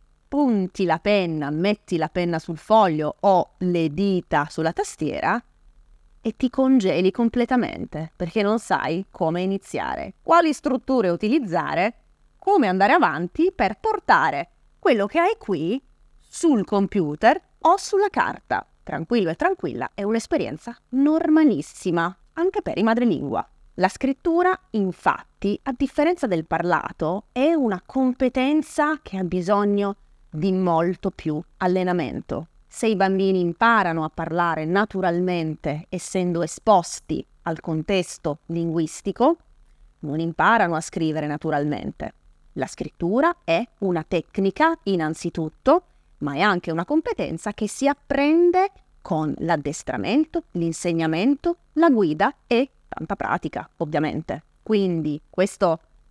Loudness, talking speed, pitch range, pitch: -22 LUFS, 115 wpm, 170-270 Hz, 195 Hz